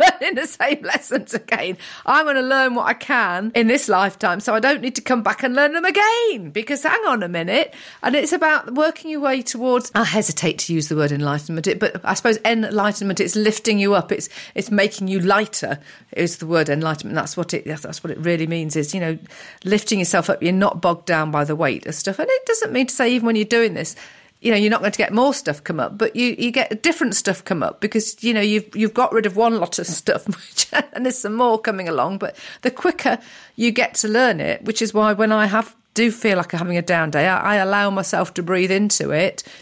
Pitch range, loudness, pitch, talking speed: 180-245 Hz, -19 LUFS, 215 Hz, 245 wpm